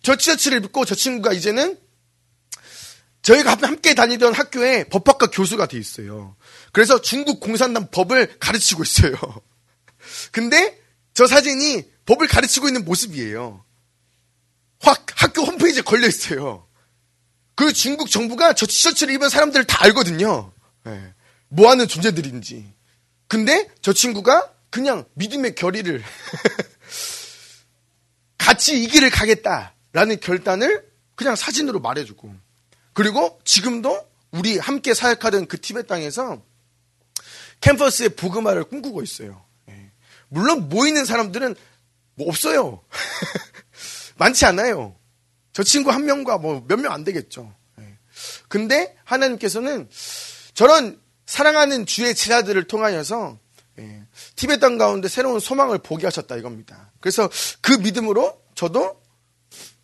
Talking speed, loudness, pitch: 270 characters per minute, -17 LUFS, 205 Hz